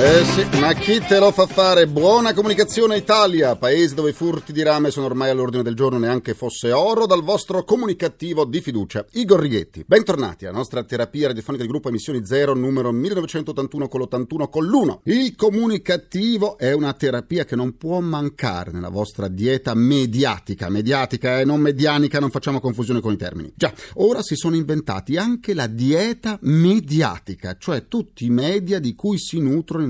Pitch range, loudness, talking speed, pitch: 125-185 Hz, -19 LUFS, 175 wpm, 145 Hz